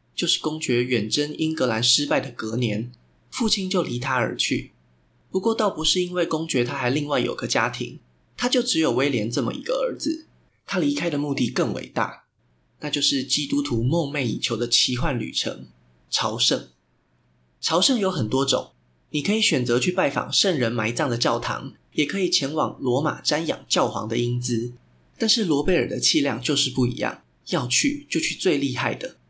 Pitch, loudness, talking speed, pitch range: 140 Hz, -23 LUFS, 270 characters per minute, 120-165 Hz